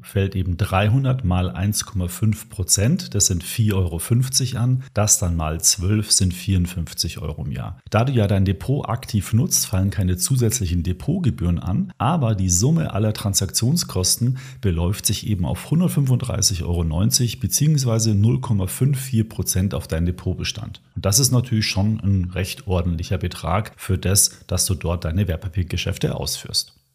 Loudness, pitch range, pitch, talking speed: -20 LUFS, 90-115 Hz, 100 Hz, 145 wpm